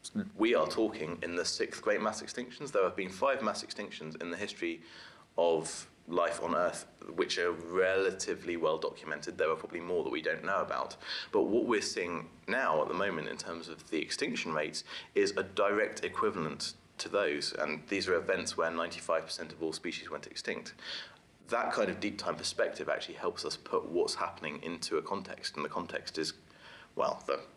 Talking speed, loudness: 190 wpm, -34 LUFS